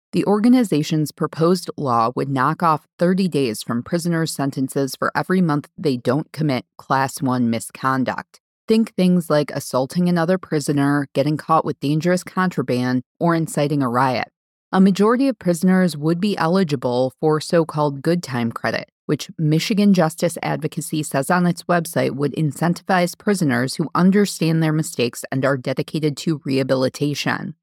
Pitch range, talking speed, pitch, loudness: 140-175 Hz, 150 wpm, 155 Hz, -20 LUFS